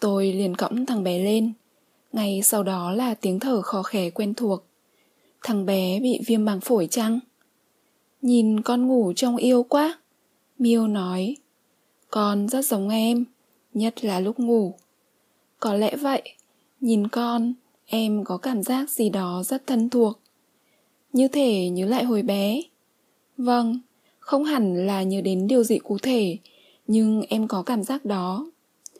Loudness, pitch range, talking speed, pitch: -23 LUFS, 205-250 Hz, 155 wpm, 225 Hz